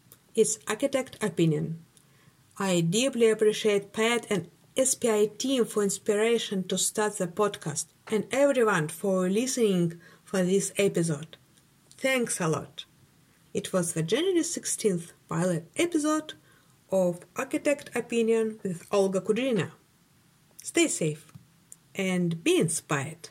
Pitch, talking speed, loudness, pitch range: 195 Hz, 115 wpm, -27 LUFS, 160-225 Hz